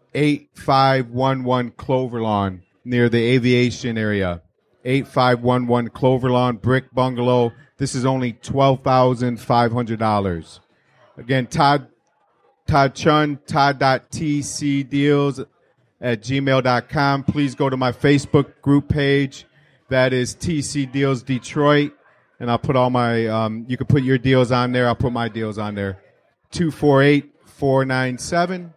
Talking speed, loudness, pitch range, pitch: 115 wpm, -19 LUFS, 120-140 Hz, 130 Hz